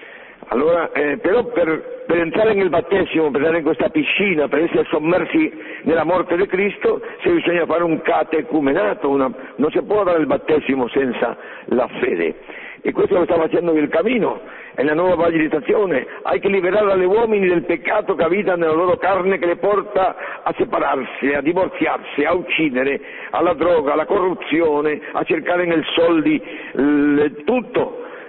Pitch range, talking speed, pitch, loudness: 160-240 Hz, 165 wpm, 180 Hz, -18 LUFS